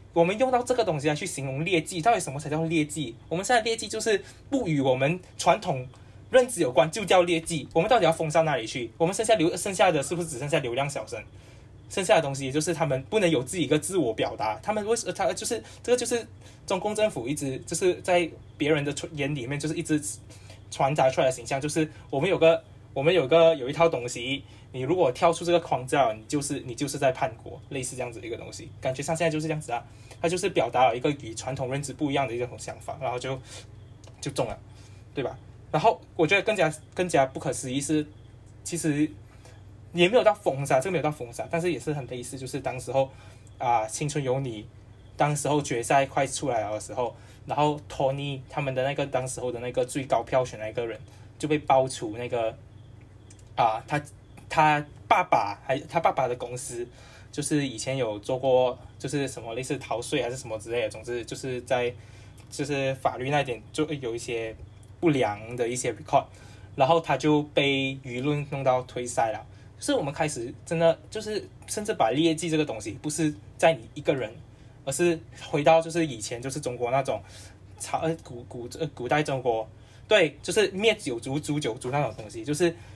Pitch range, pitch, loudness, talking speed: 120-165 Hz, 135 Hz, -27 LUFS, 315 characters per minute